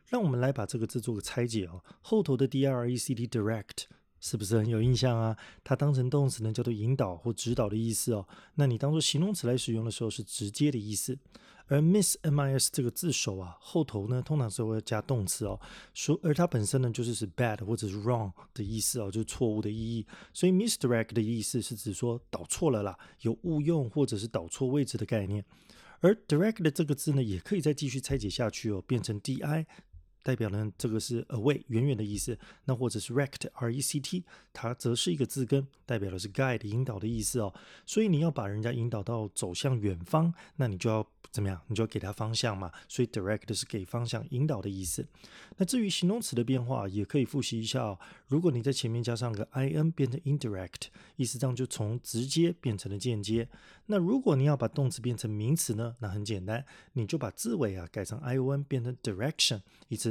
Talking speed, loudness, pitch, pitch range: 370 characters per minute, -31 LUFS, 120 Hz, 110-140 Hz